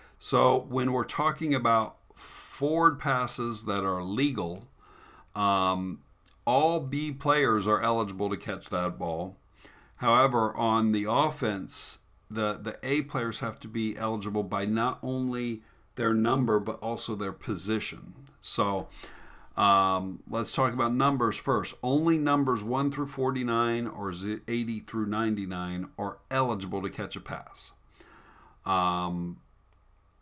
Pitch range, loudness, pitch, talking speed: 100-130 Hz, -28 LUFS, 110 Hz, 125 wpm